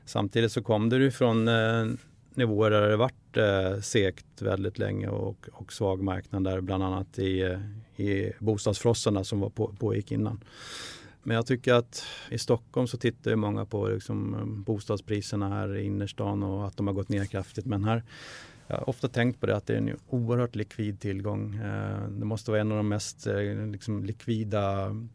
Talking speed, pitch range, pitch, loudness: 175 wpm, 100-115 Hz, 105 Hz, -29 LUFS